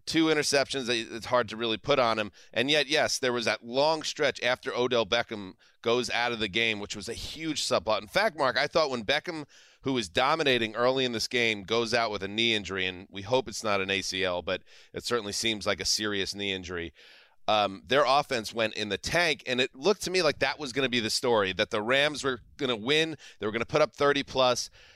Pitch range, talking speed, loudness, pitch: 105-135 Hz, 245 wpm, -27 LUFS, 115 Hz